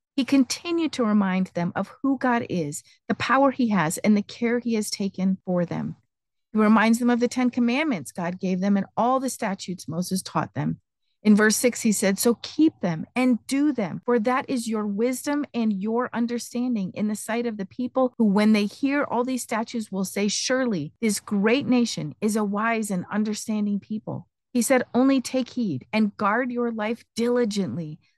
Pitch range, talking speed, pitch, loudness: 200-245 Hz, 195 wpm, 220 Hz, -24 LUFS